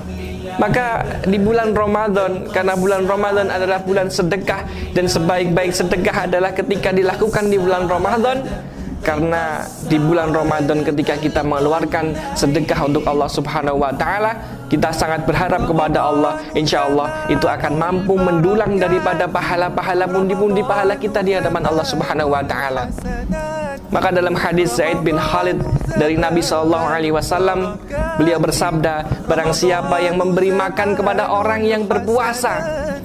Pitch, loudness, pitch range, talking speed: 180 Hz, -17 LUFS, 155-195 Hz, 140 wpm